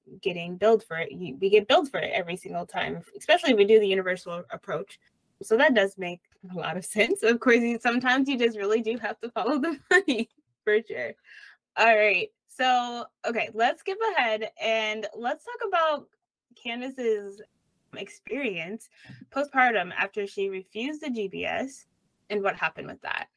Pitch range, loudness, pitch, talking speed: 200-275 Hz, -26 LUFS, 225 Hz, 170 wpm